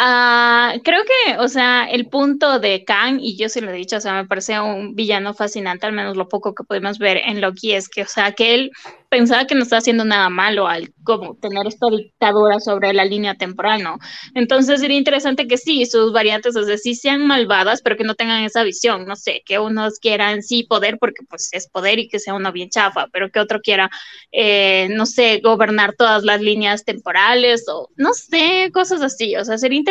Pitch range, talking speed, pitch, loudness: 205-245 Hz, 220 wpm, 220 Hz, -16 LUFS